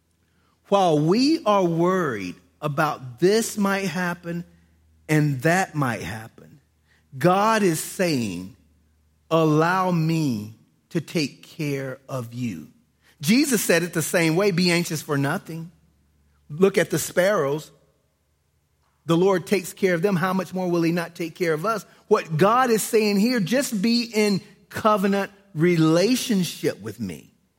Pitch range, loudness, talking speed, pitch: 130-195 Hz, -22 LUFS, 140 wpm, 170 Hz